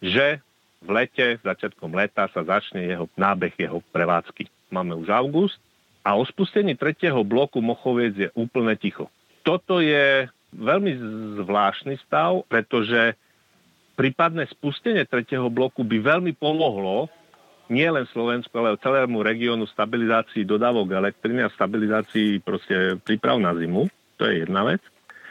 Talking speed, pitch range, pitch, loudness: 130 wpm, 110-145 Hz, 120 Hz, -23 LUFS